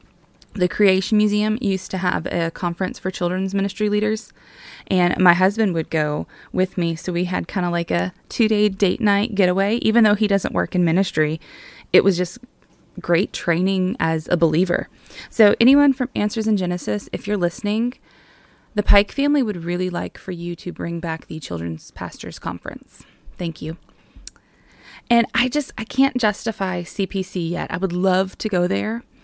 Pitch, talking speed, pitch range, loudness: 190 Hz, 175 wpm, 175-210 Hz, -21 LUFS